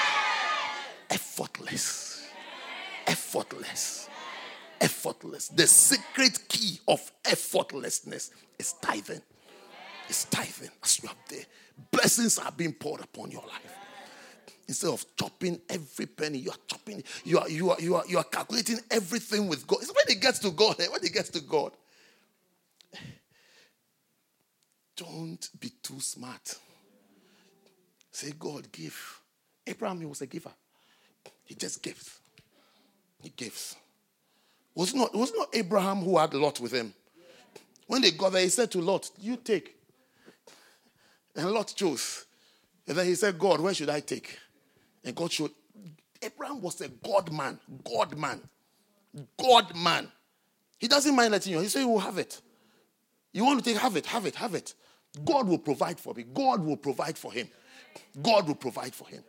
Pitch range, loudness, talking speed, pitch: 170-235 Hz, -28 LUFS, 155 wpm, 195 Hz